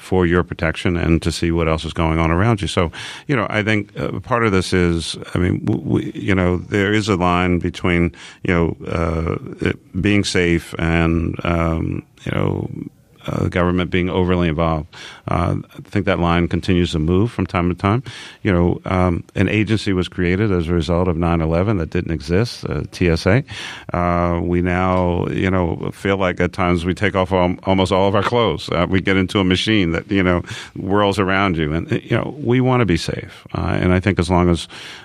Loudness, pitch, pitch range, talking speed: -18 LUFS, 90 Hz, 85-100 Hz, 210 wpm